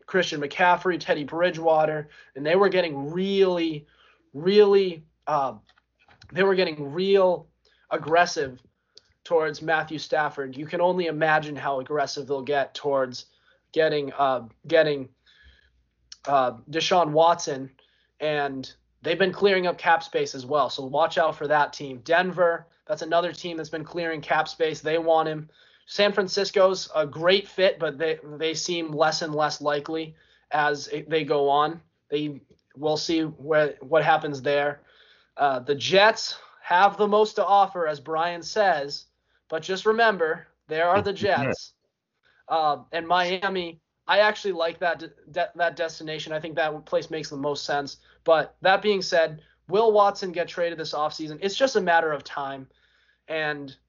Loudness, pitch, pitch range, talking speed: -24 LUFS, 160 Hz, 145-175 Hz, 155 wpm